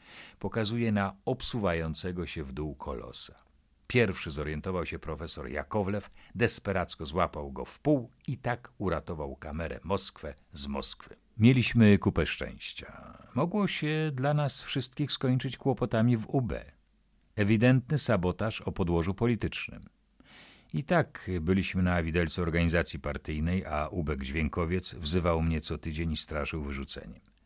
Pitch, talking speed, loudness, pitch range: 90 Hz, 125 wpm, -31 LUFS, 80-115 Hz